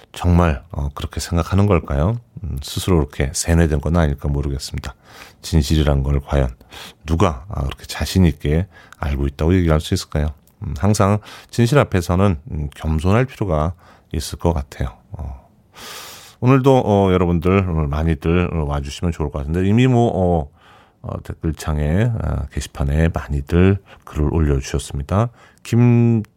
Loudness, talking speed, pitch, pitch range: -19 LUFS, 285 characters per minute, 85 Hz, 75-100 Hz